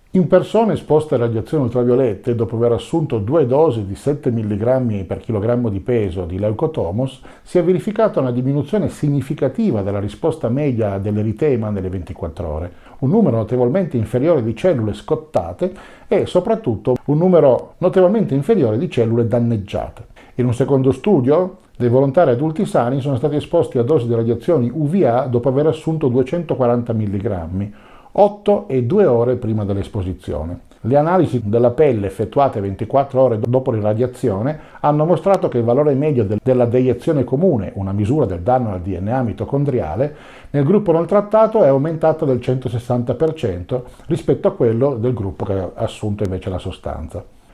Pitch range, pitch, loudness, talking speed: 110-155 Hz, 125 Hz, -17 LUFS, 150 wpm